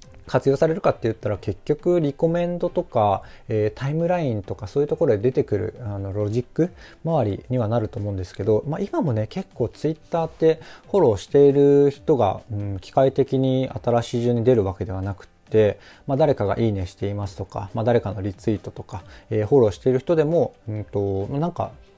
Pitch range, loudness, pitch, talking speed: 105-140 Hz, -22 LUFS, 120 Hz, 430 characters per minute